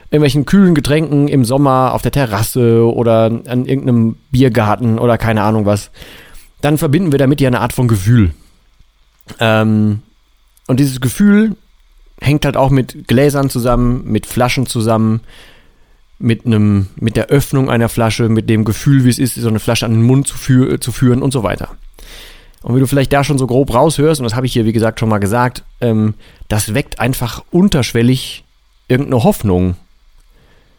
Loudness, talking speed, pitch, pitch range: -13 LUFS, 175 wpm, 125 Hz, 110-135 Hz